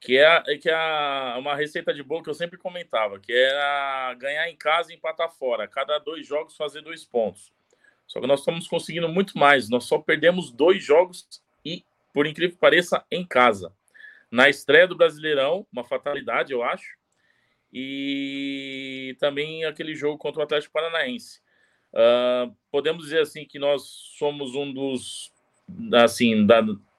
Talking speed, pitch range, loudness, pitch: 160 wpm, 135-170 Hz, -23 LUFS, 150 Hz